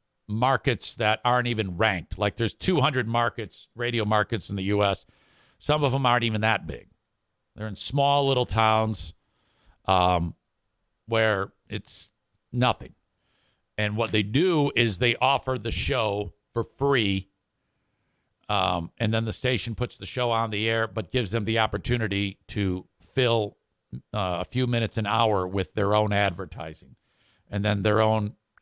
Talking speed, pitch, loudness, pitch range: 155 wpm, 110 Hz, -25 LUFS, 100-120 Hz